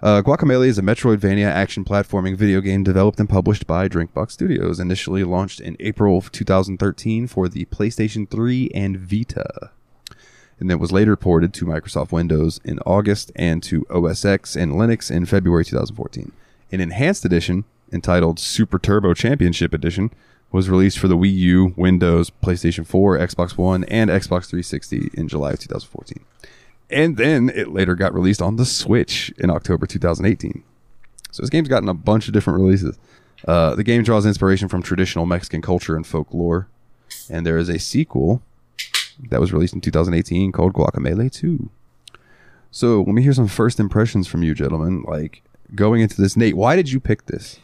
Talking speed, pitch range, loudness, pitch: 170 wpm, 85-105 Hz, -19 LUFS, 95 Hz